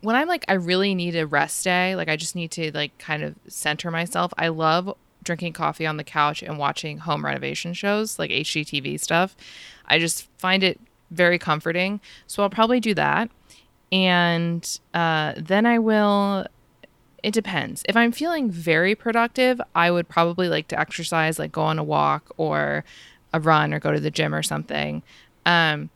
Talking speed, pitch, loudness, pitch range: 185 wpm, 170 Hz, -22 LUFS, 150-190 Hz